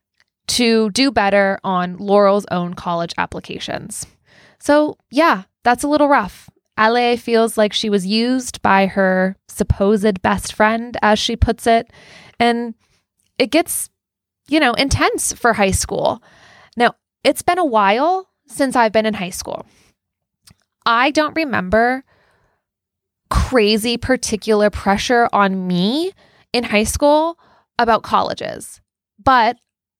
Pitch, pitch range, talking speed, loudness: 230 Hz, 200-265 Hz, 125 wpm, -17 LUFS